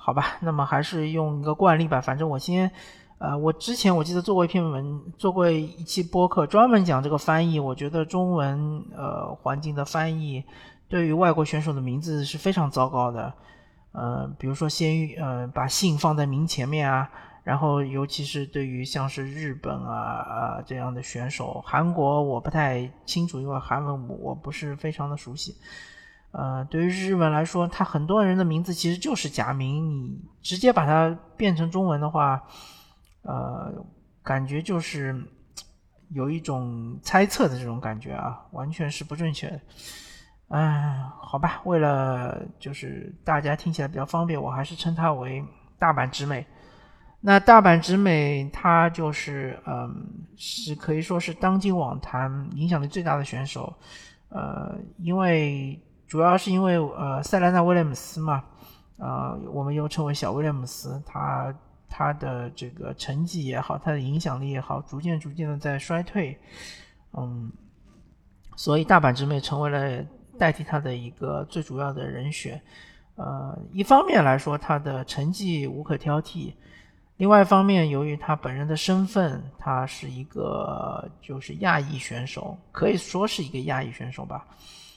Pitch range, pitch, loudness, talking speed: 135-170 Hz, 150 Hz, -25 LUFS, 250 characters per minute